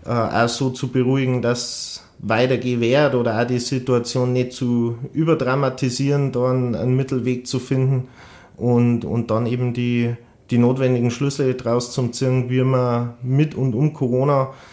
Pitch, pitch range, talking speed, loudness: 125 Hz, 120-130 Hz, 145 wpm, -20 LUFS